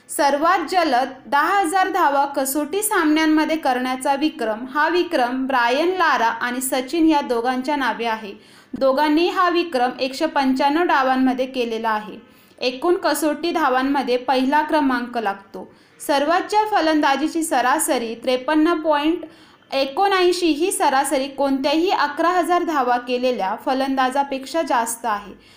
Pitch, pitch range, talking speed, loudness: 285 Hz, 255-325 Hz, 115 wpm, -19 LUFS